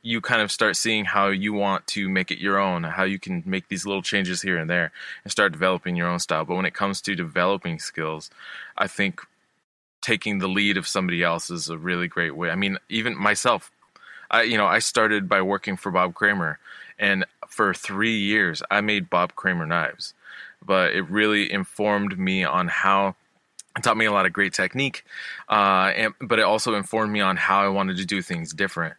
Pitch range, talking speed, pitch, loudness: 90-100 Hz, 210 wpm, 95 Hz, -23 LUFS